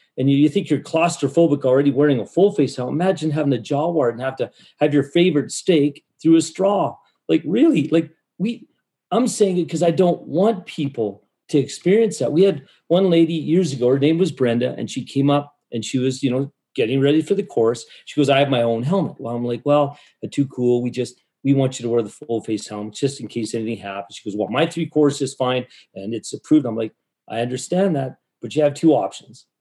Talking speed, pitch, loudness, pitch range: 230 wpm, 145 Hz, -20 LUFS, 125-165 Hz